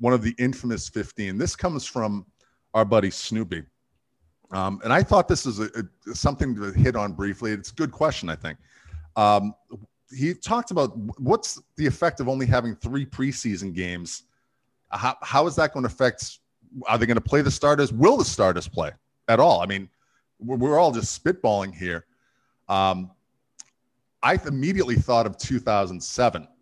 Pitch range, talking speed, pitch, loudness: 100-130 Hz, 180 wpm, 115 Hz, -24 LUFS